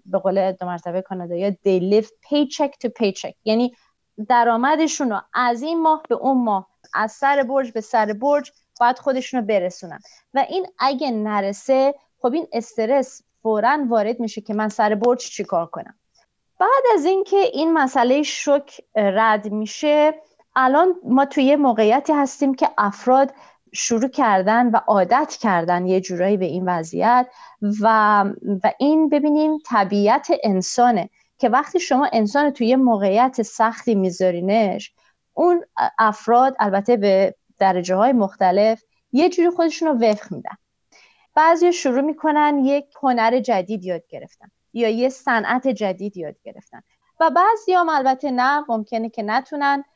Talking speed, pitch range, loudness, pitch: 145 wpm, 210-285 Hz, -19 LUFS, 245 Hz